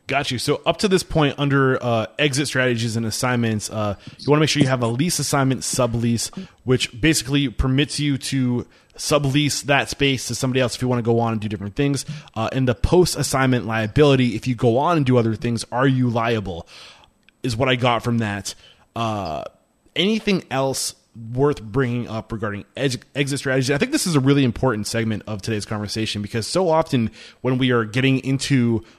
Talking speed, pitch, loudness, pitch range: 205 wpm, 125 Hz, -21 LUFS, 115-140 Hz